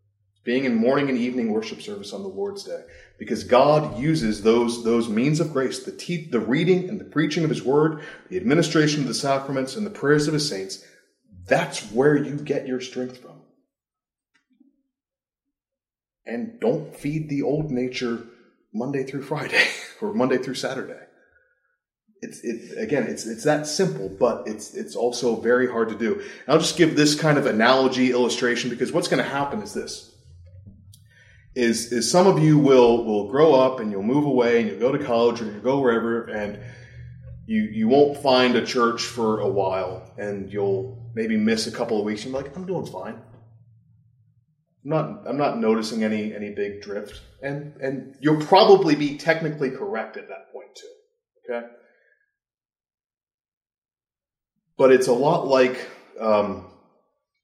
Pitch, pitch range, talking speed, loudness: 130 Hz, 115-160 Hz, 170 wpm, -22 LUFS